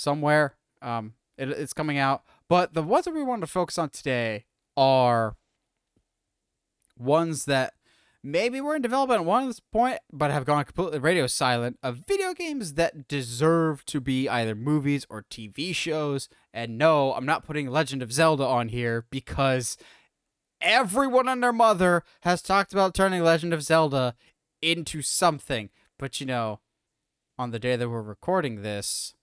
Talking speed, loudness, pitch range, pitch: 160 wpm, -25 LUFS, 125-170 Hz, 150 Hz